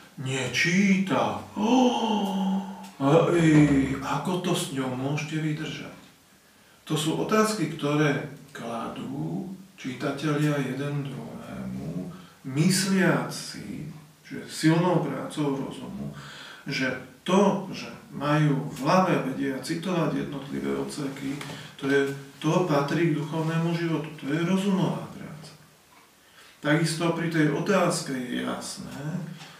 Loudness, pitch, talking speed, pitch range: -26 LUFS, 155 Hz, 100 wpm, 140-175 Hz